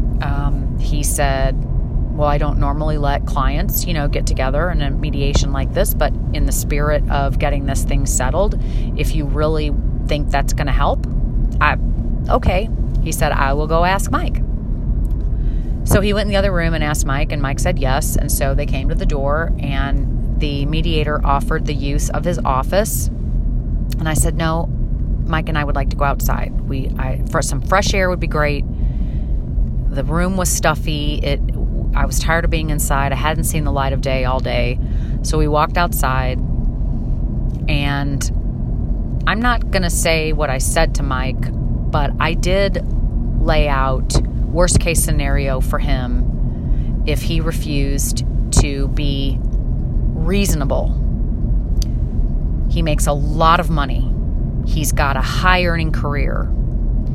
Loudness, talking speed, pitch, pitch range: -19 LUFS, 165 wpm, 140 Hz, 120-155 Hz